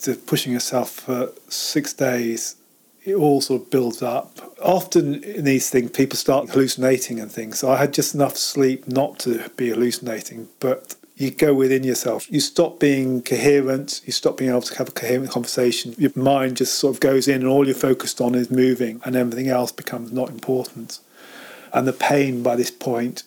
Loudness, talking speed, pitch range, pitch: -21 LUFS, 195 wpm, 125-140 Hz, 130 Hz